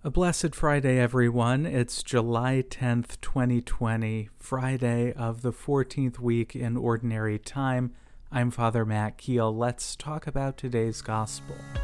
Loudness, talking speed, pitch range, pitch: -28 LUFS, 125 wpm, 115-130 Hz, 120 Hz